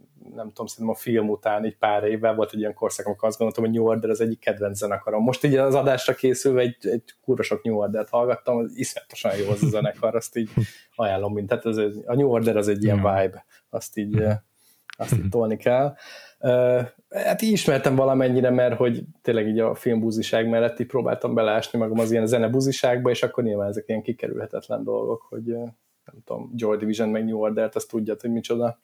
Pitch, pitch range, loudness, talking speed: 115 Hz, 110-125 Hz, -23 LUFS, 200 wpm